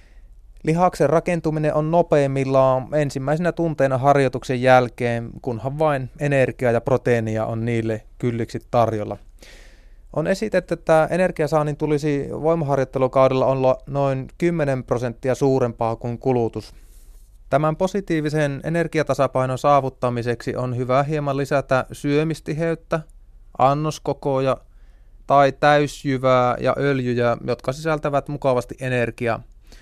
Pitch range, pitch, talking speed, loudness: 120-150 Hz, 135 Hz, 95 wpm, -21 LUFS